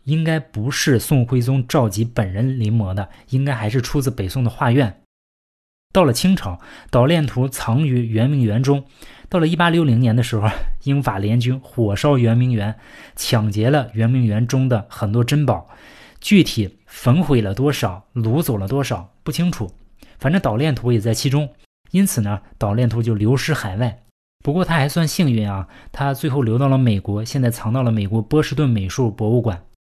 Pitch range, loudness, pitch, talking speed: 110-140 Hz, -19 LUFS, 125 Hz, 270 characters per minute